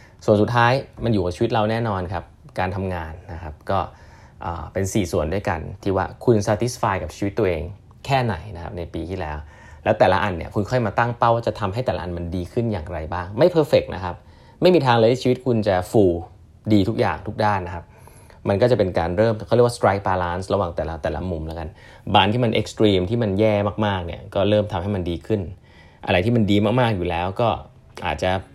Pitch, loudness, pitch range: 100 Hz, -21 LUFS, 90-110 Hz